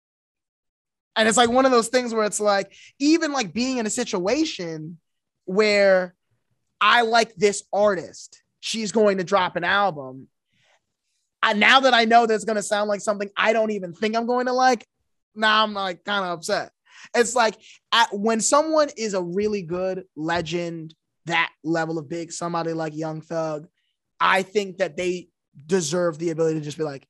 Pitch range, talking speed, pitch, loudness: 170-225 Hz, 180 wpm, 195 Hz, -22 LUFS